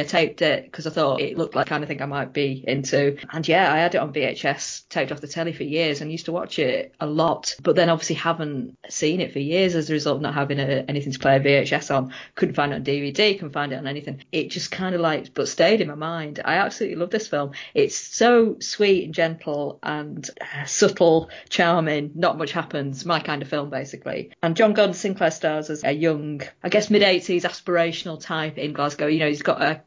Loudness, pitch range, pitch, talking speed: -22 LUFS, 145-175 Hz, 155 Hz, 245 wpm